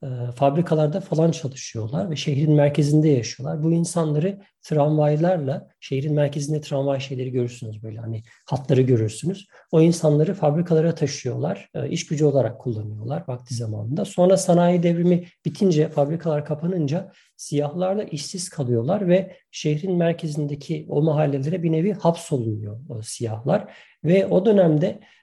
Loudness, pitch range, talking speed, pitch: -22 LUFS, 135-170 Hz, 120 wpm, 150 Hz